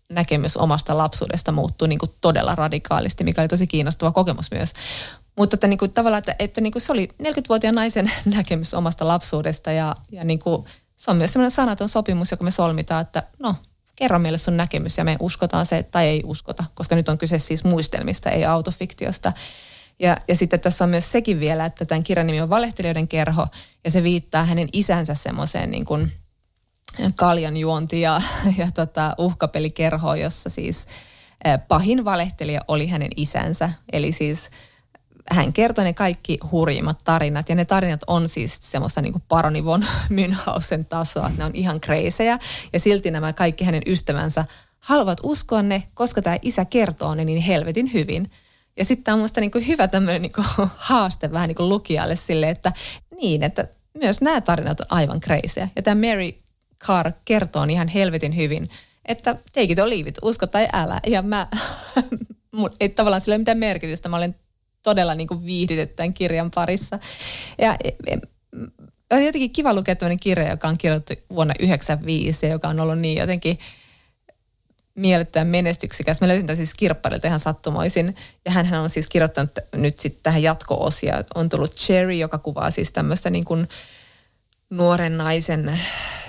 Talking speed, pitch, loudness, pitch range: 170 wpm, 170 Hz, -21 LUFS, 160-195 Hz